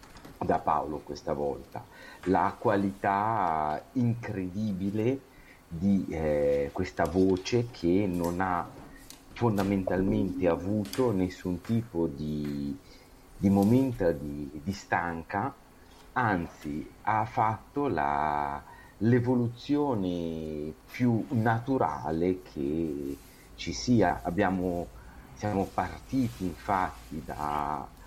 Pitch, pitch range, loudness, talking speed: 95 Hz, 80-110 Hz, -30 LUFS, 85 wpm